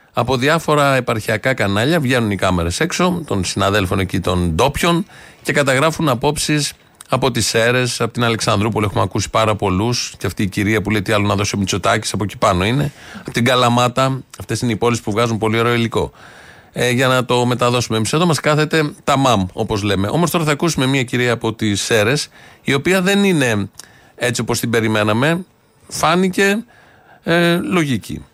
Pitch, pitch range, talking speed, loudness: 120 Hz, 105-150 Hz, 185 wpm, -16 LUFS